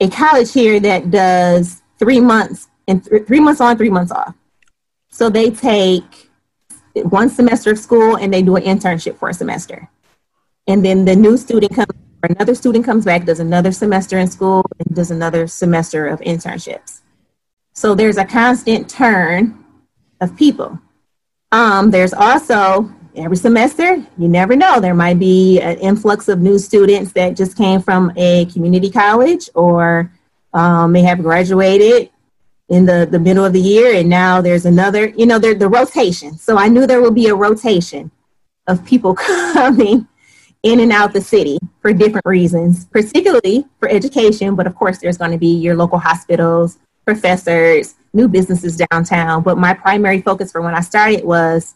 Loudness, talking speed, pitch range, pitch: -12 LUFS, 170 wpm, 175-220 Hz, 190 Hz